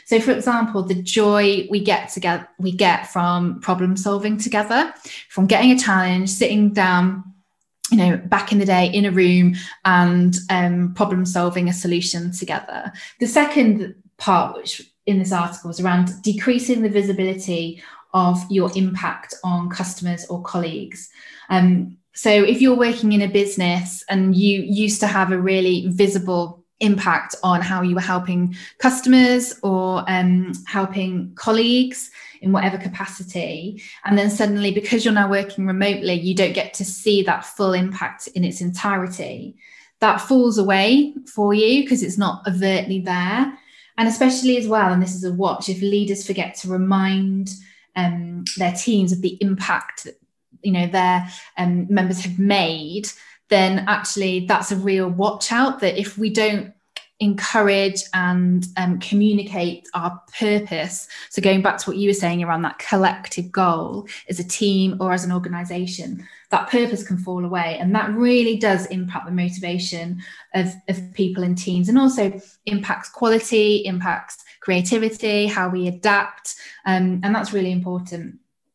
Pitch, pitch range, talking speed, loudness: 190 Hz, 180-210 Hz, 160 wpm, -19 LUFS